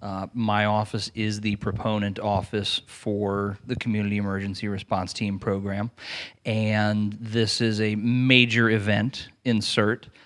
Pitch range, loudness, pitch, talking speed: 100-115 Hz, -25 LUFS, 105 Hz, 125 wpm